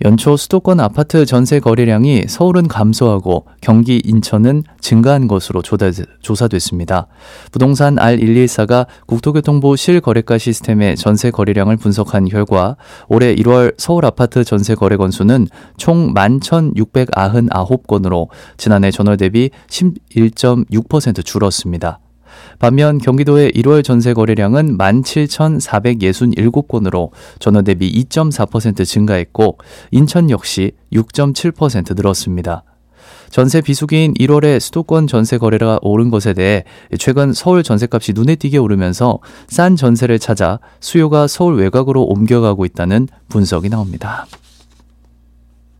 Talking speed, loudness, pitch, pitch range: 260 characters per minute, -12 LUFS, 115 Hz, 100-140 Hz